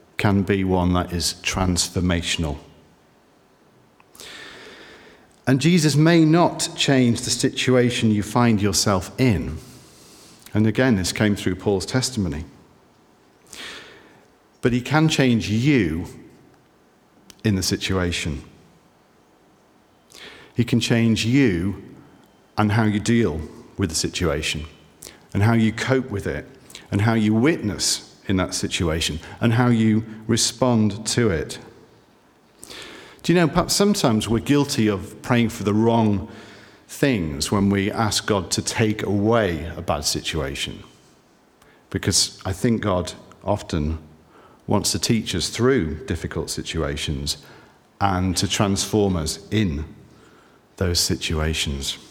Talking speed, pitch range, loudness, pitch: 120 wpm, 85-115 Hz, -21 LUFS, 105 Hz